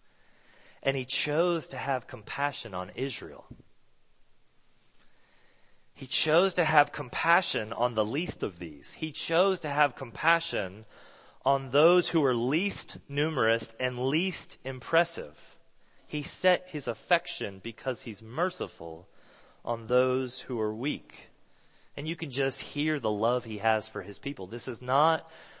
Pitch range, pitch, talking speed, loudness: 115-160 Hz, 135 Hz, 140 wpm, -29 LUFS